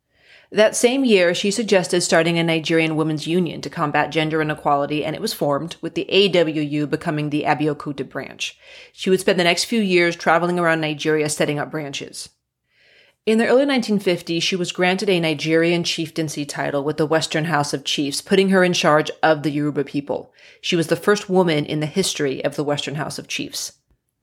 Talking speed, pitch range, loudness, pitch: 190 wpm, 150-185 Hz, -20 LUFS, 165 Hz